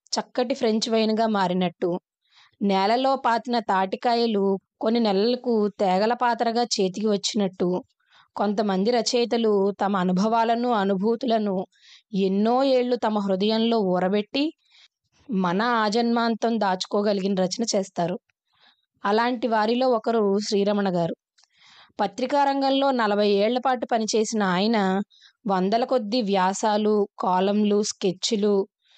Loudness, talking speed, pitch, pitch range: -23 LUFS, 95 wpm, 215 Hz, 195-235 Hz